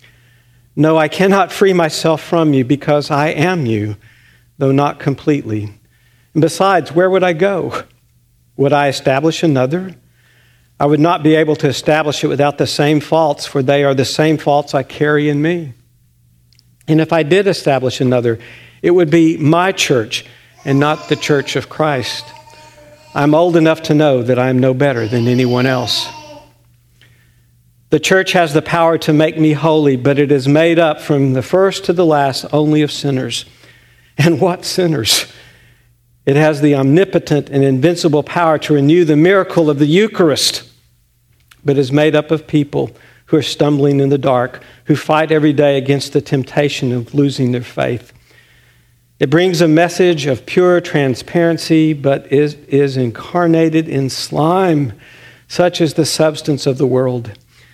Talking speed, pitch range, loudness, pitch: 165 wpm, 125-160 Hz, -13 LUFS, 145 Hz